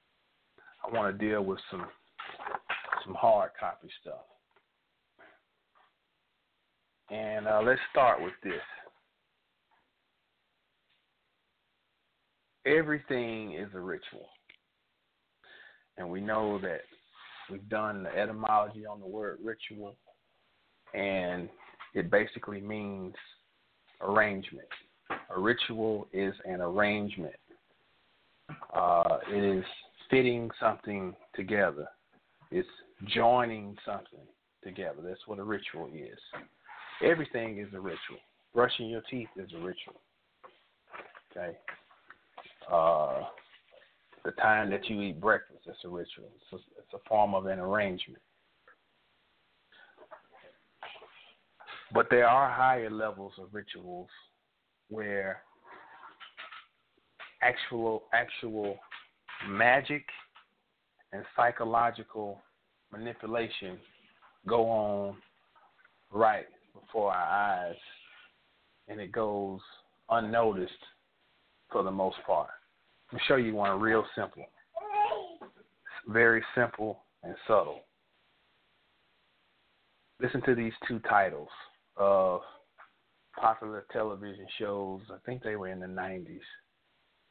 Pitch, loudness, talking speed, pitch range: 105 Hz, -31 LUFS, 95 wpm, 100-115 Hz